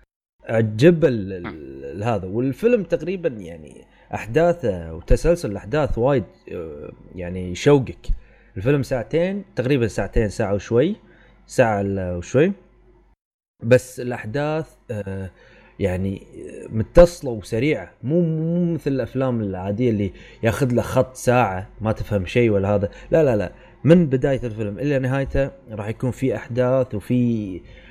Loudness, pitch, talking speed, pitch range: -21 LUFS, 120 Hz, 110 wpm, 100-140 Hz